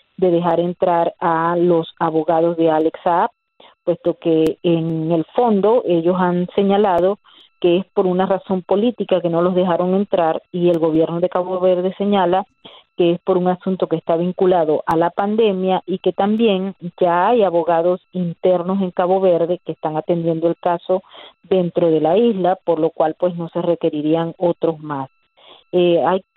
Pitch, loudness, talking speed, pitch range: 175 Hz, -18 LUFS, 170 wpm, 165-185 Hz